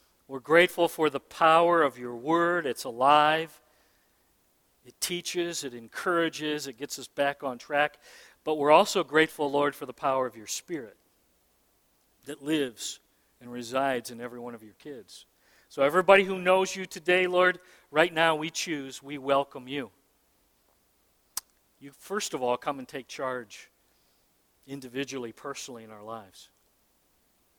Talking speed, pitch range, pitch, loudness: 150 wpm, 130-160 Hz, 145 Hz, -27 LUFS